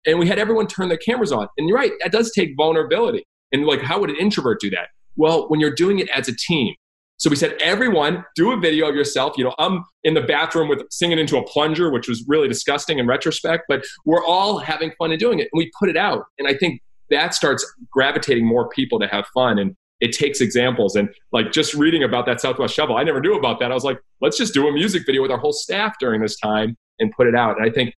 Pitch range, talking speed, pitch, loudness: 135-185 Hz, 260 wpm, 155 Hz, -19 LUFS